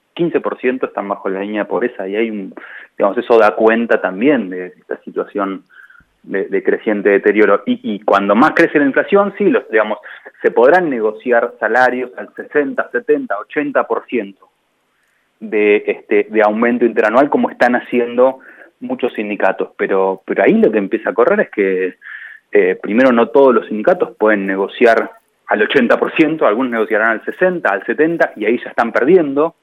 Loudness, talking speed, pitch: -14 LUFS, 165 wpm, 125 Hz